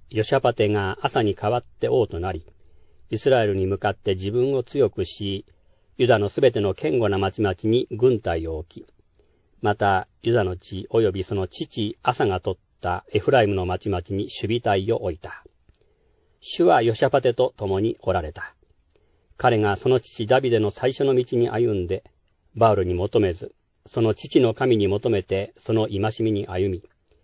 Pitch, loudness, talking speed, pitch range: 105 Hz, -23 LUFS, 300 characters per minute, 95-120 Hz